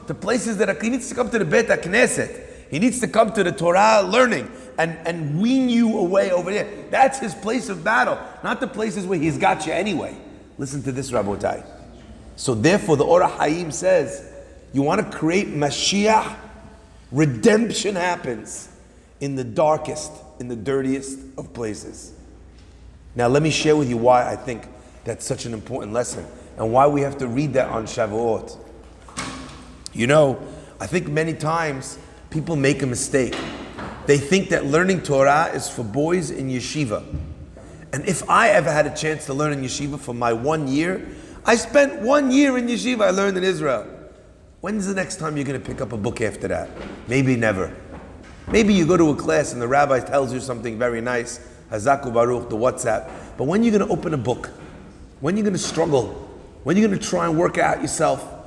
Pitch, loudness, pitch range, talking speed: 145 Hz, -21 LUFS, 125-190 Hz, 195 wpm